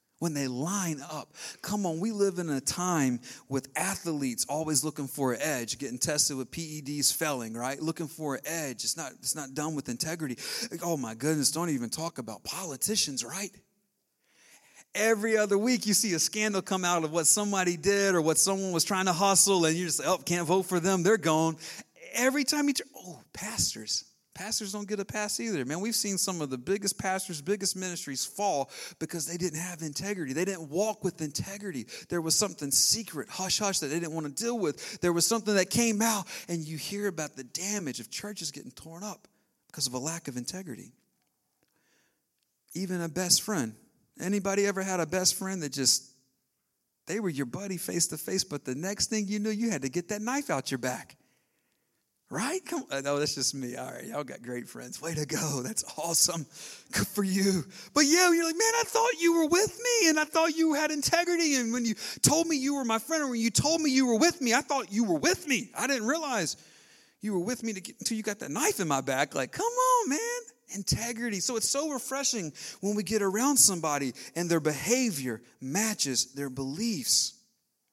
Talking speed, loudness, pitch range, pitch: 215 wpm, -28 LUFS, 155-220 Hz, 185 Hz